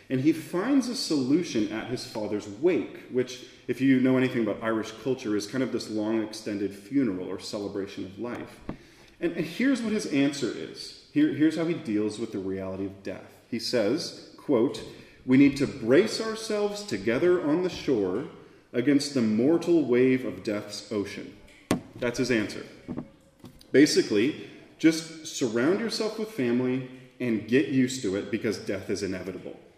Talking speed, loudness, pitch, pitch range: 165 wpm, -27 LUFS, 130 Hz, 110-180 Hz